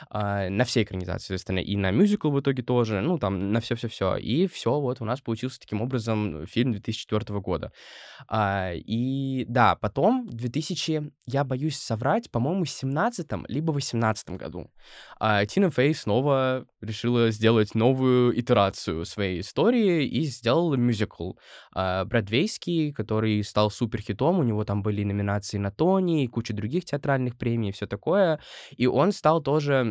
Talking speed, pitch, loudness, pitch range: 155 wpm, 120 Hz, -26 LUFS, 105-140 Hz